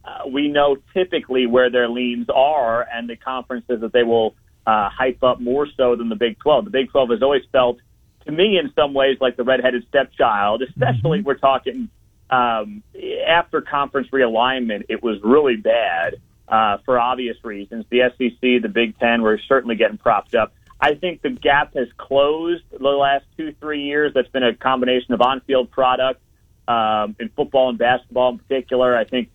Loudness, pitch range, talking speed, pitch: -19 LUFS, 120-140 Hz, 185 wpm, 130 Hz